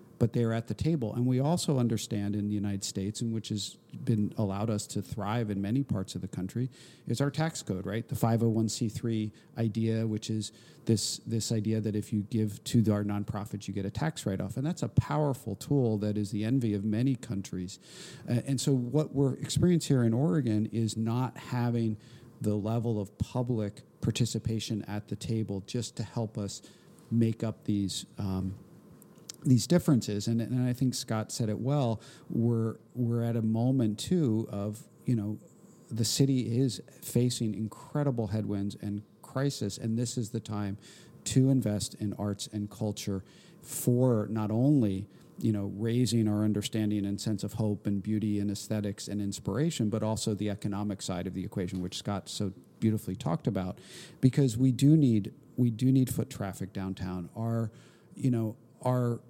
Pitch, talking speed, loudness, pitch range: 115 Hz, 180 wpm, -31 LUFS, 105-125 Hz